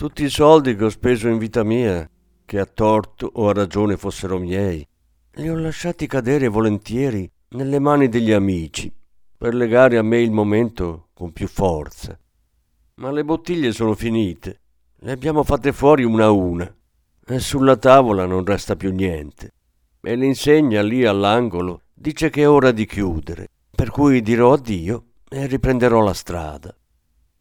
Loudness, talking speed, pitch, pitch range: -18 LUFS, 160 wpm, 110 Hz, 90-130 Hz